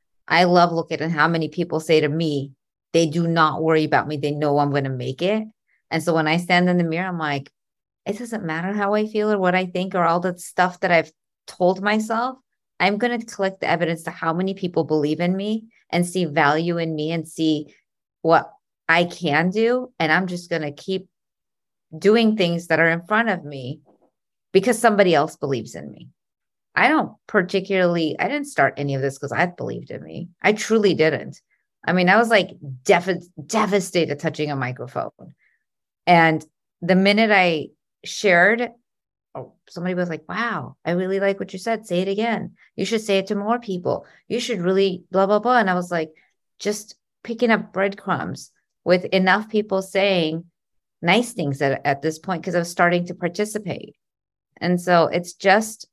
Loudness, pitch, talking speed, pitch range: -21 LUFS, 180 Hz, 195 wpm, 160-200 Hz